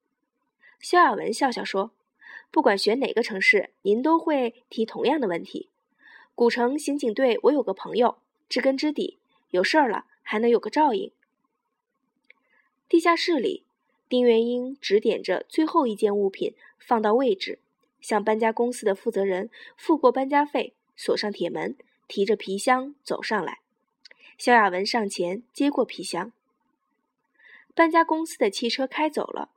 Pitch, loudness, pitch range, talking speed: 255 Hz, -24 LUFS, 220-330 Hz, 225 characters per minute